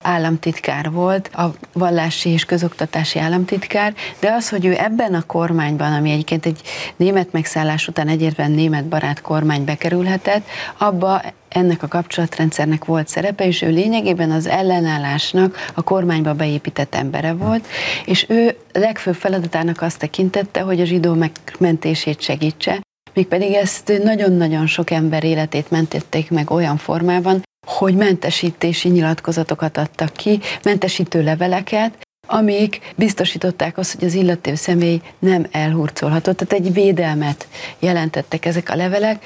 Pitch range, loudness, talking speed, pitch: 160-190 Hz, -18 LUFS, 130 wpm, 170 Hz